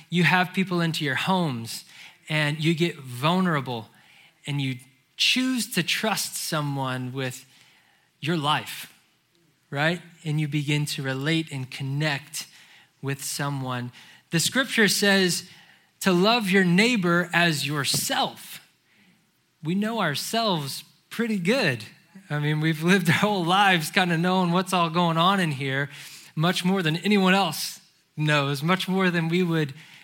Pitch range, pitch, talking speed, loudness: 145-185 Hz, 165 Hz, 140 wpm, -24 LUFS